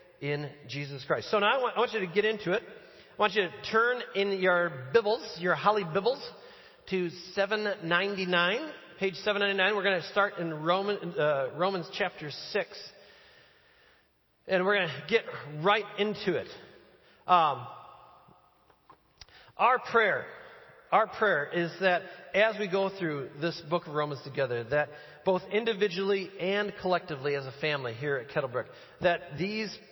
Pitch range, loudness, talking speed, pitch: 165-205 Hz, -29 LUFS, 150 wpm, 190 Hz